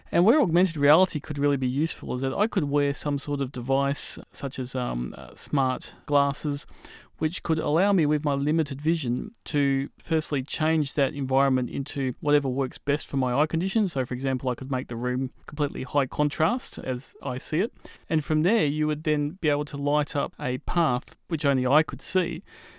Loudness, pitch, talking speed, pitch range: -26 LUFS, 145 Hz, 205 wpm, 135-155 Hz